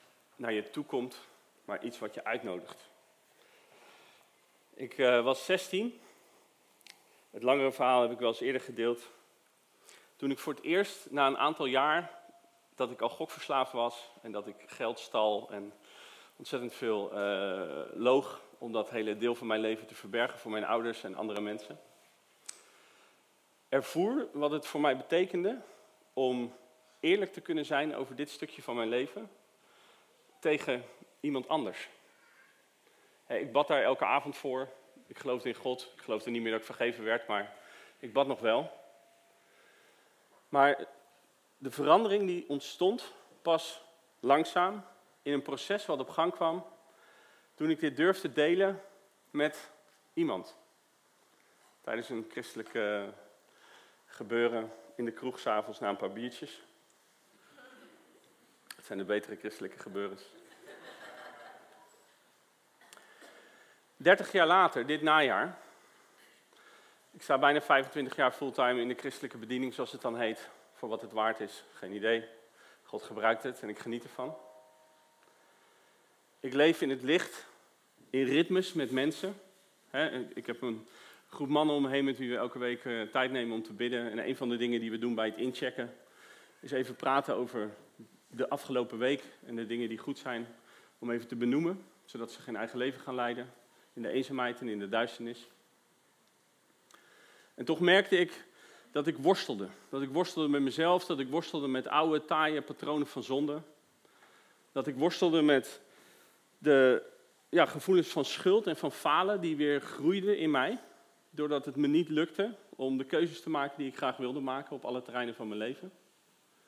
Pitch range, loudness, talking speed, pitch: 120-155 Hz, -32 LUFS, 155 wpm, 135 Hz